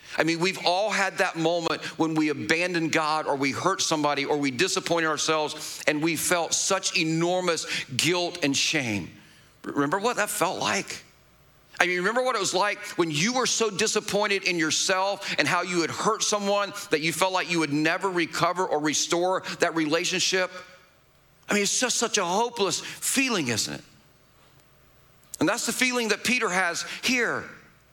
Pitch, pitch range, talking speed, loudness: 180 Hz, 160-200 Hz, 175 wpm, -25 LUFS